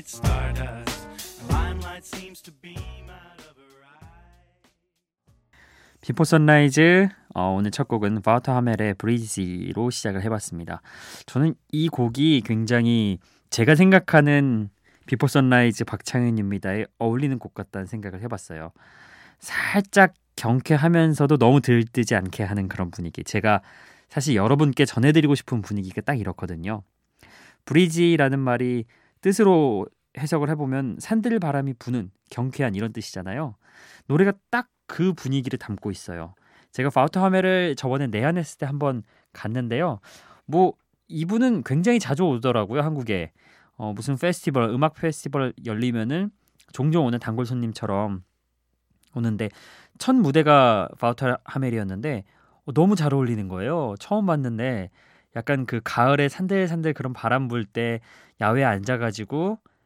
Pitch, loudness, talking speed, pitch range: 125 Hz, -22 LUFS, 290 characters per minute, 105-155 Hz